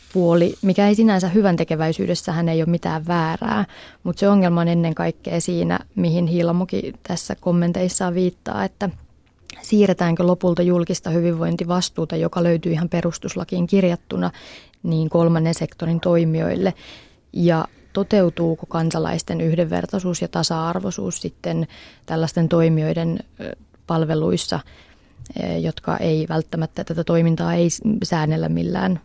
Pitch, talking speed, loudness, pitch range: 170 Hz, 110 wpm, -20 LUFS, 165-180 Hz